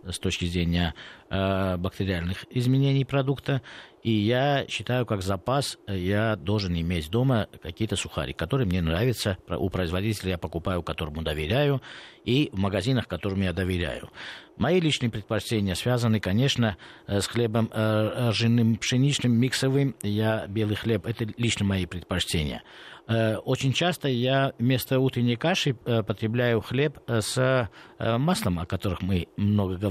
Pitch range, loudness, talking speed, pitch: 95-125 Hz, -26 LUFS, 140 wpm, 110 Hz